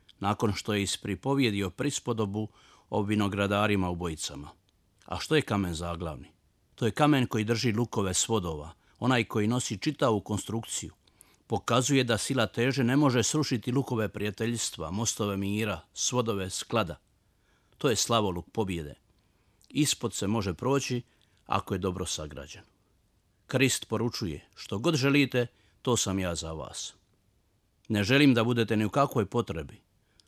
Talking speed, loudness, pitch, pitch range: 140 wpm, -29 LUFS, 105 Hz, 95-120 Hz